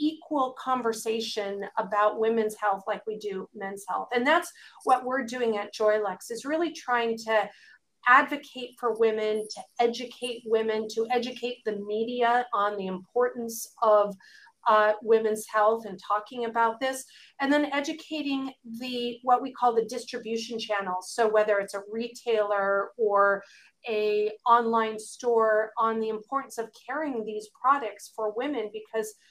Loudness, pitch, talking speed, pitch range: -27 LUFS, 225 Hz, 145 wpm, 215-245 Hz